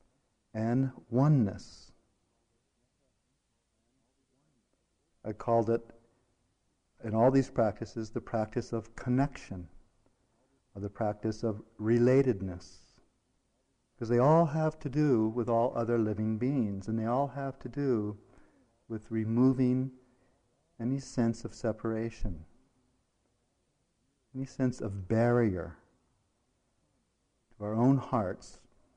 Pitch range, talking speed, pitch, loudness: 110-130 Hz, 100 wpm, 115 Hz, -31 LUFS